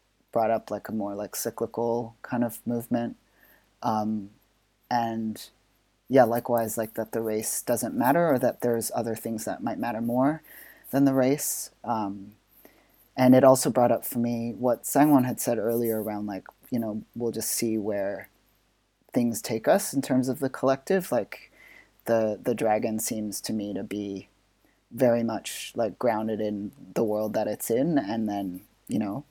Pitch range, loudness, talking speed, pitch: 110-120 Hz, -27 LUFS, 170 wpm, 115 Hz